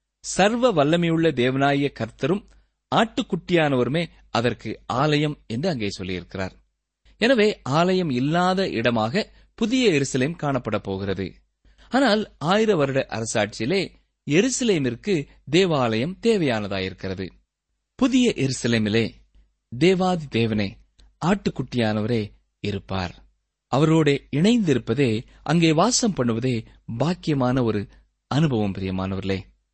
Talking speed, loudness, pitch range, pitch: 80 wpm, -22 LUFS, 105-175 Hz, 130 Hz